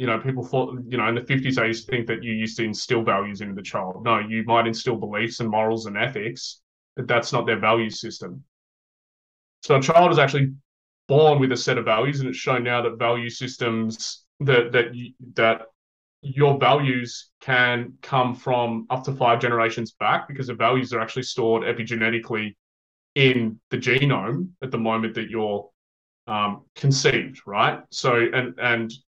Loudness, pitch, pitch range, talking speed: -22 LUFS, 115 Hz, 110-130 Hz, 185 wpm